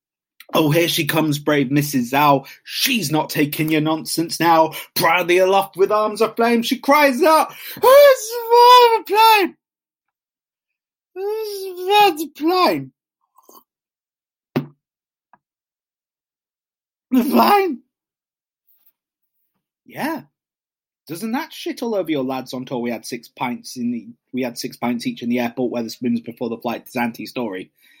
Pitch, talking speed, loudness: 190 Hz, 135 wpm, -17 LUFS